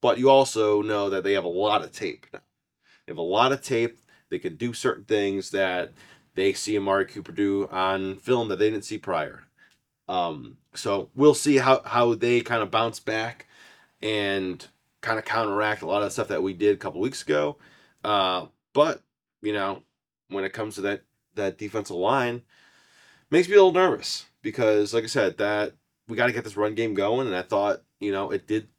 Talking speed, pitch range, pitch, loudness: 210 wpm, 100-115 Hz, 105 Hz, -25 LUFS